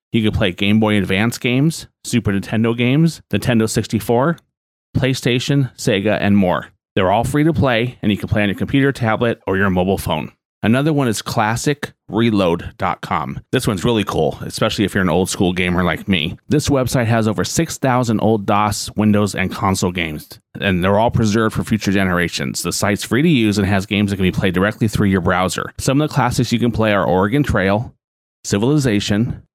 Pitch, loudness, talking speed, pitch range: 110 Hz, -17 LUFS, 195 wpm, 100-125 Hz